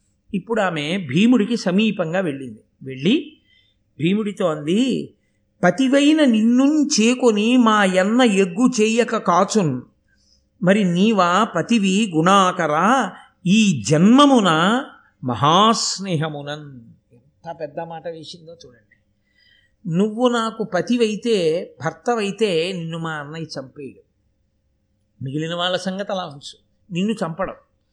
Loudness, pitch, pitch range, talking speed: -18 LUFS, 190 Hz, 160-225 Hz, 90 wpm